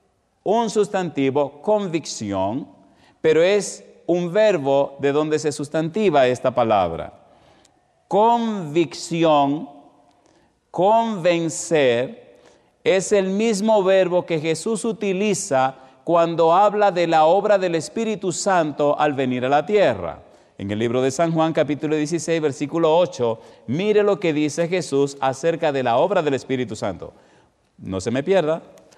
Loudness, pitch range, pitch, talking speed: -20 LUFS, 145-200 Hz, 165 Hz, 125 wpm